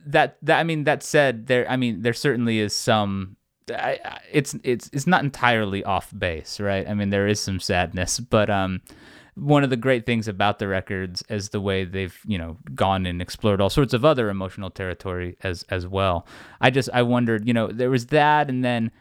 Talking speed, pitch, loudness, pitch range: 210 wpm, 110 Hz, -23 LUFS, 95-125 Hz